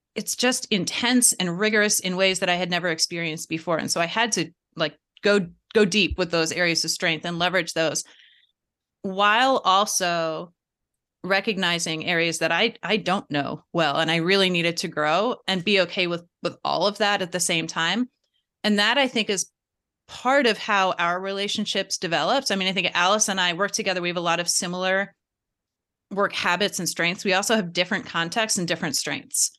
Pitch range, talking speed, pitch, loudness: 170-205 Hz, 195 wpm, 185 Hz, -22 LUFS